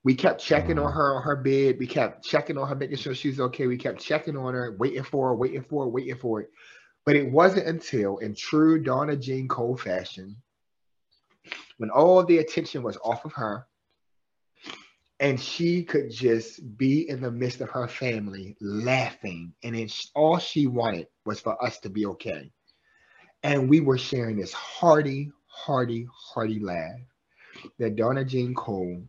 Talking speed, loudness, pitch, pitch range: 175 wpm, -26 LUFS, 130 Hz, 115-140 Hz